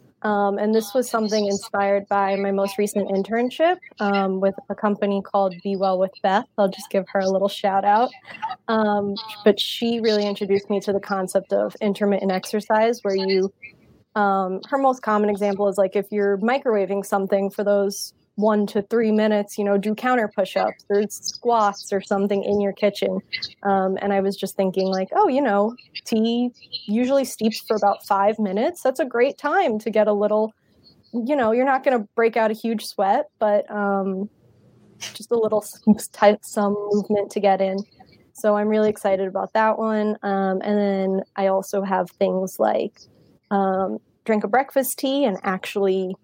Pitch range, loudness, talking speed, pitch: 195-220 Hz, -22 LUFS, 185 wpm, 205 Hz